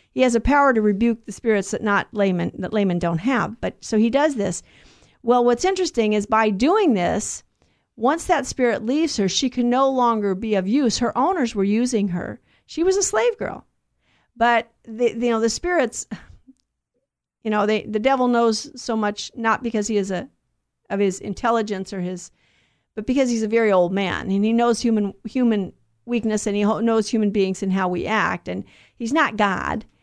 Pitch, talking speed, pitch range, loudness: 225 Hz, 200 wpm, 205-245 Hz, -21 LUFS